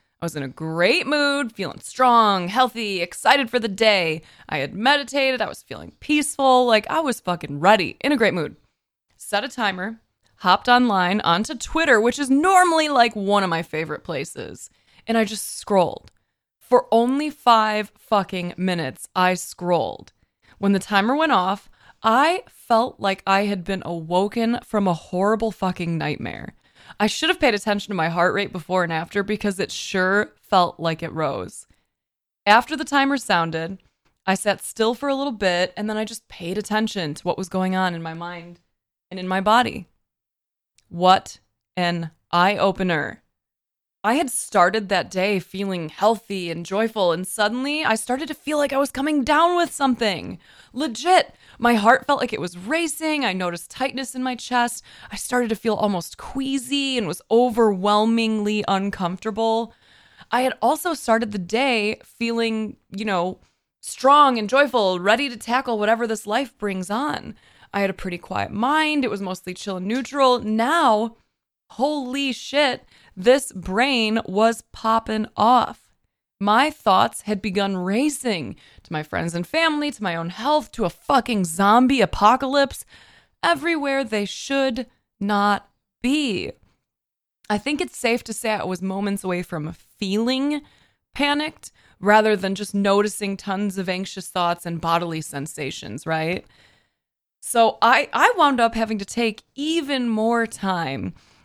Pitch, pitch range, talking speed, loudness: 215 Hz, 185-255 Hz, 160 wpm, -21 LUFS